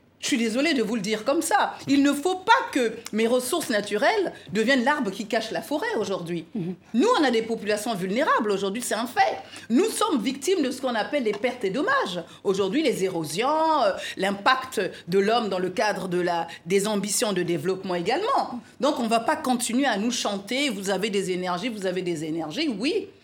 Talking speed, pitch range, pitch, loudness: 205 wpm, 195-275 Hz, 230 Hz, -24 LUFS